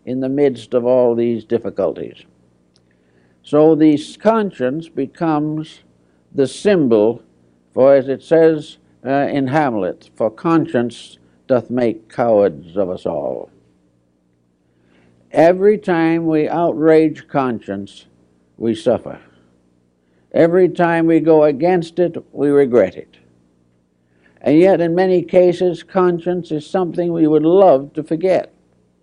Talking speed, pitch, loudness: 120 wpm, 135 Hz, -16 LUFS